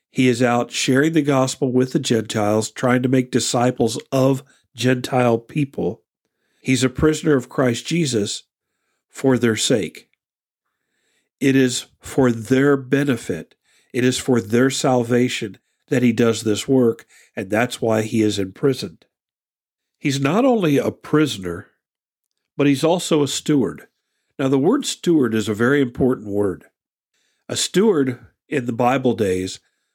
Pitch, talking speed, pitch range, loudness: 130 Hz, 140 wpm, 120-140 Hz, -19 LUFS